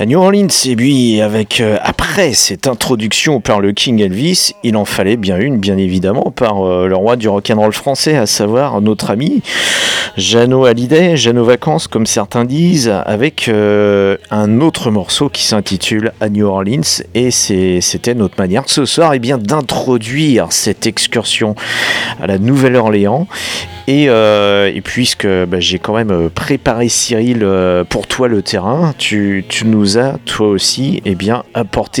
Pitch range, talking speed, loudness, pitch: 100-125 Hz, 170 wpm, -12 LUFS, 110 Hz